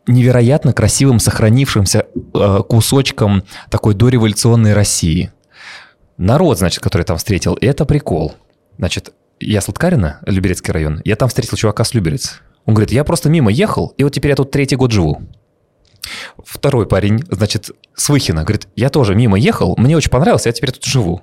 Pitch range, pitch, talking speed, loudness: 100-130 Hz, 110 Hz, 165 wpm, -14 LUFS